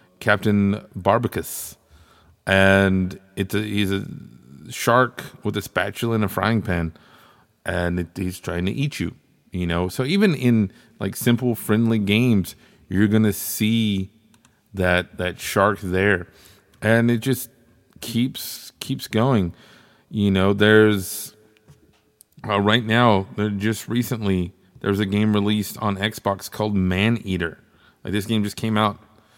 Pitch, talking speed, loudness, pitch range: 105 Hz, 140 wpm, -21 LUFS, 95-115 Hz